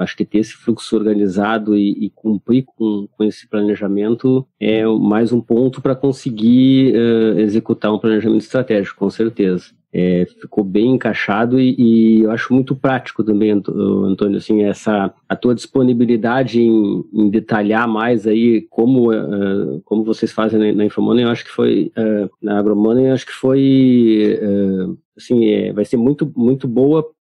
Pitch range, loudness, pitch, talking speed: 105-120 Hz, -15 LUFS, 110 Hz, 165 wpm